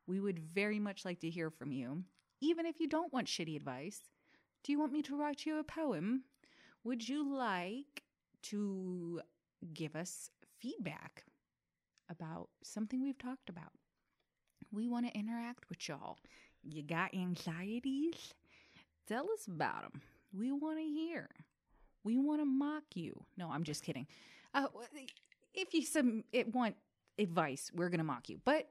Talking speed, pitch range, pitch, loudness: 155 wpm, 175-285 Hz, 235 Hz, -41 LUFS